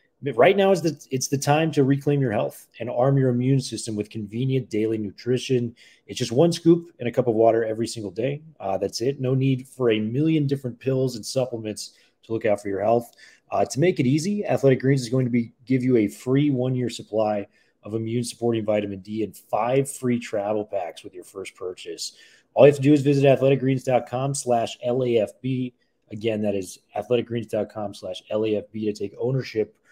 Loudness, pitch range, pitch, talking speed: -23 LUFS, 110-135 Hz, 125 Hz, 195 wpm